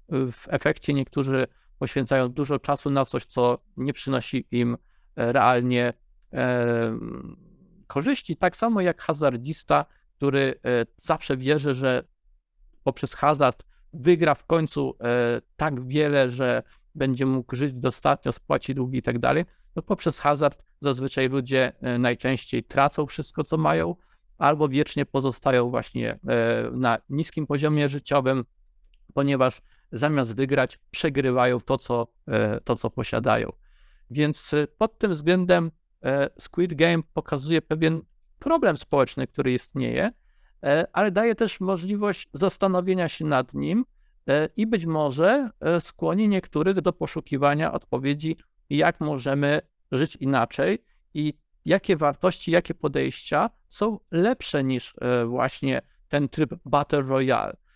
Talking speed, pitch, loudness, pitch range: 120 wpm, 145 Hz, -25 LUFS, 130-160 Hz